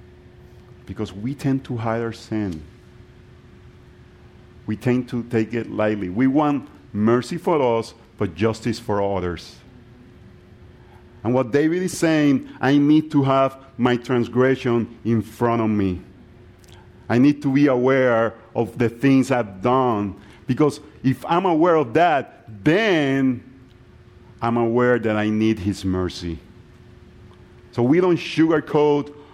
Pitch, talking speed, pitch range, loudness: 120 Hz, 135 wpm, 105-130 Hz, -20 LUFS